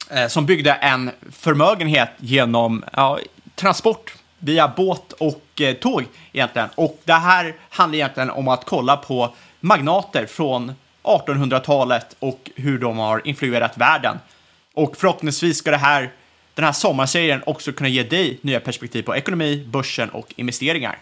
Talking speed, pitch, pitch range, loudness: 140 wpm, 140 Hz, 130-160 Hz, -19 LUFS